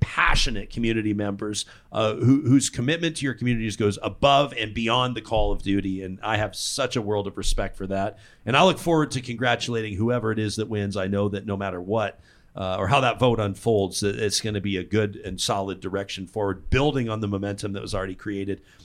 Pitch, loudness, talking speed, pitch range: 105 Hz, -24 LUFS, 225 wpm, 100-120 Hz